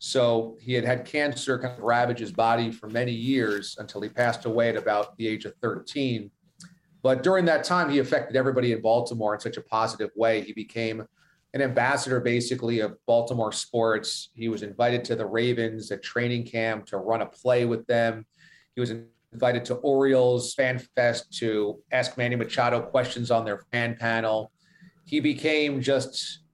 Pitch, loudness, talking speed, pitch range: 120 Hz, -26 LUFS, 180 wpm, 115-130 Hz